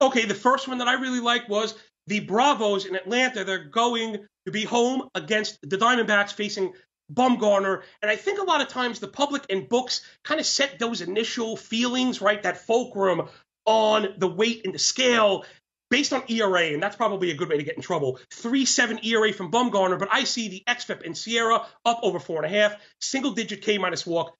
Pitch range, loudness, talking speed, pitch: 195-245 Hz, -24 LUFS, 200 wpm, 220 Hz